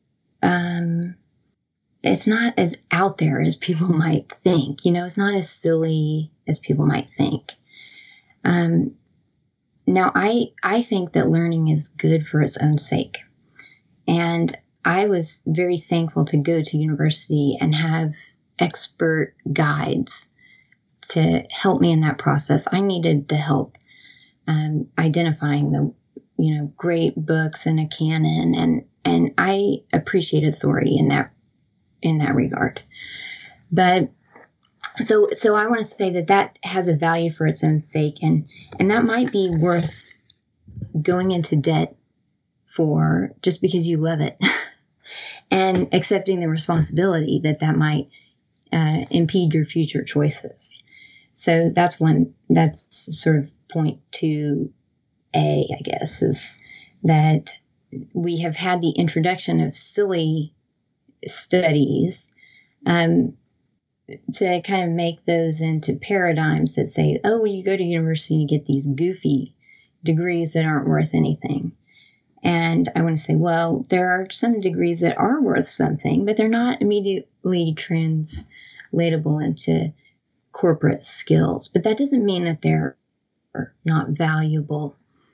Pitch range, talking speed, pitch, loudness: 145-180 Hz, 135 wpm, 160 Hz, -21 LUFS